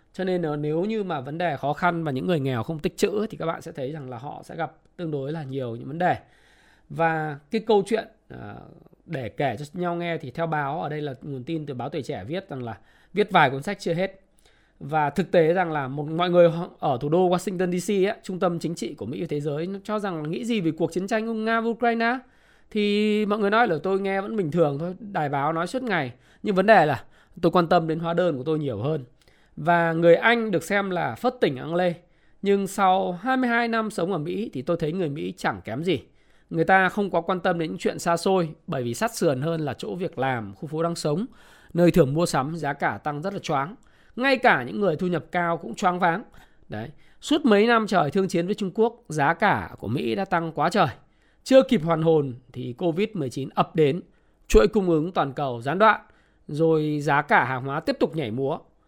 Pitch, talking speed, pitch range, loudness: 170 Hz, 245 wpm, 155-200 Hz, -24 LUFS